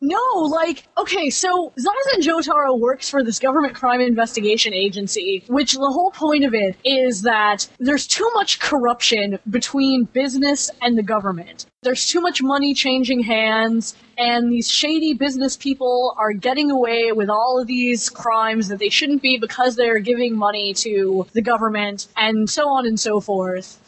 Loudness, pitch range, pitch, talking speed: -18 LUFS, 220-280 Hz, 250 Hz, 165 wpm